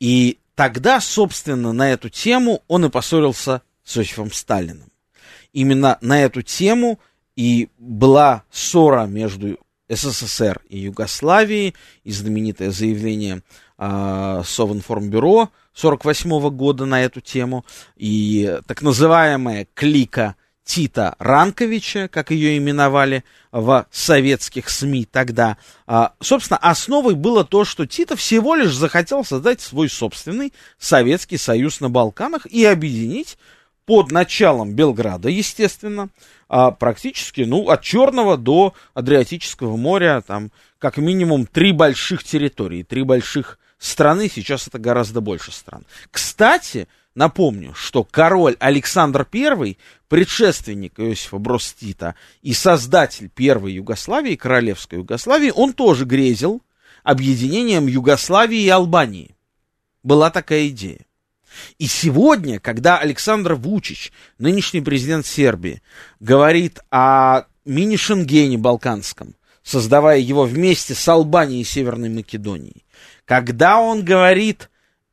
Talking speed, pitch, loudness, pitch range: 110 wpm, 135 Hz, -16 LUFS, 115-175 Hz